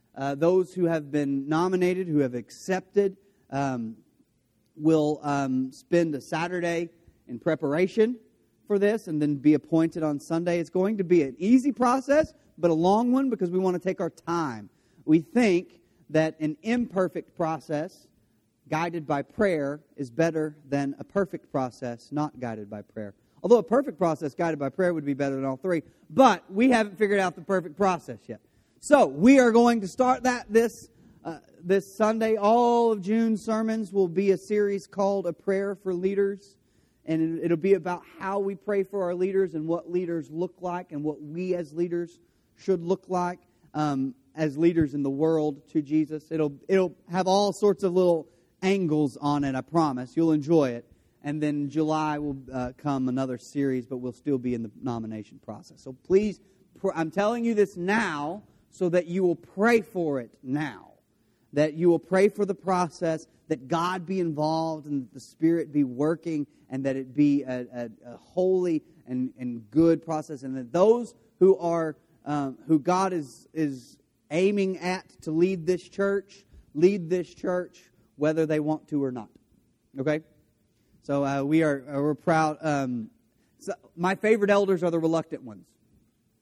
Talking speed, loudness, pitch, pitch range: 180 wpm, -26 LUFS, 165 Hz, 145-190 Hz